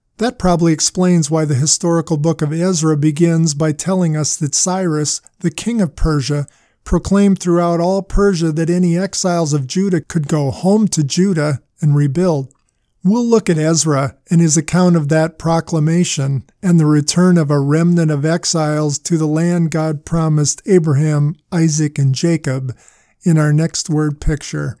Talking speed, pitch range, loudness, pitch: 160 wpm, 150-175 Hz, -15 LUFS, 160 Hz